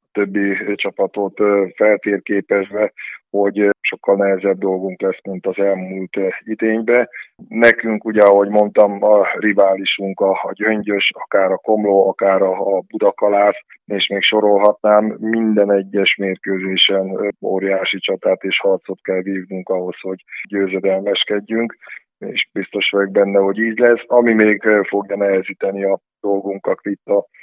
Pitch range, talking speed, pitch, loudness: 95-105 Hz, 125 wpm, 100 Hz, -16 LUFS